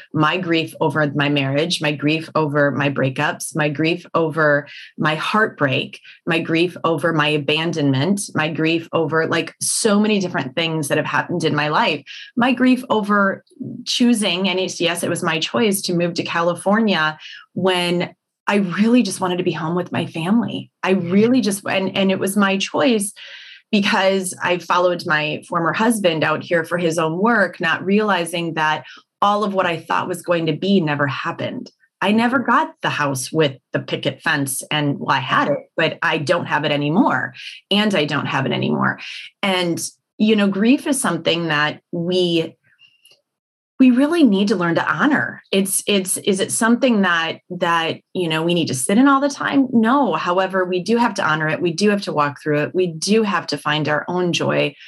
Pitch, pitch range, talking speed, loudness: 175 Hz, 155-200 Hz, 195 wpm, -18 LUFS